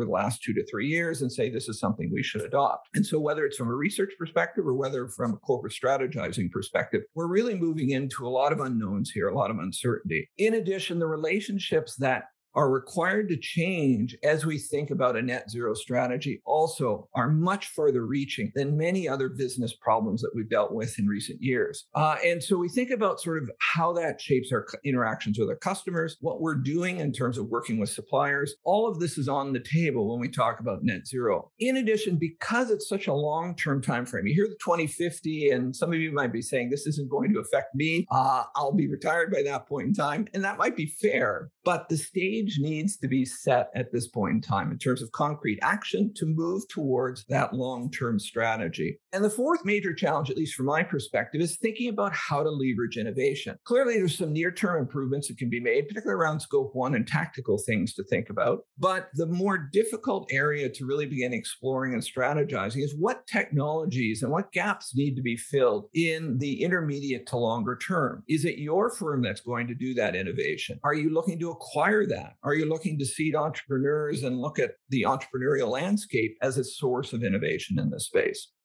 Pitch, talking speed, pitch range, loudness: 155 Hz, 210 wpm, 130-185 Hz, -28 LUFS